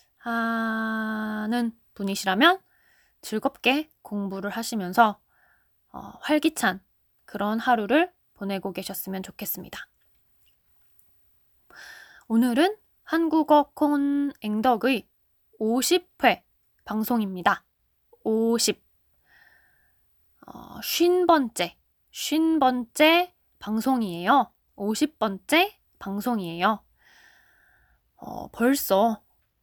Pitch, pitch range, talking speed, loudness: 230 Hz, 205-295 Hz, 155 characters per minute, -25 LUFS